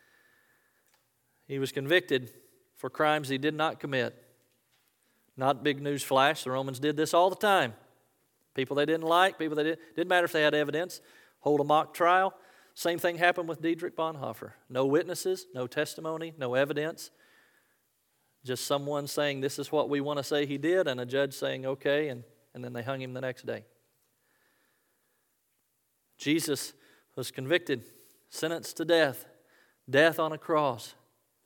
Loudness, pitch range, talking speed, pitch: -29 LUFS, 135-165 Hz, 160 wpm, 150 Hz